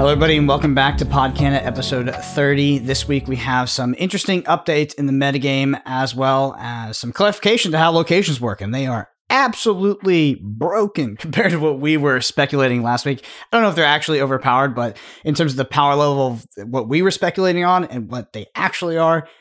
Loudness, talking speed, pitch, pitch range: -18 LUFS, 205 wpm, 140 Hz, 130-165 Hz